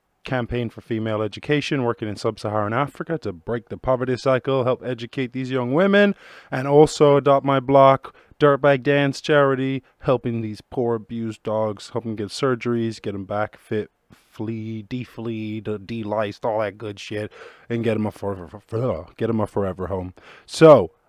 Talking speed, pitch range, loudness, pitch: 160 wpm, 105-135 Hz, -22 LUFS, 115 Hz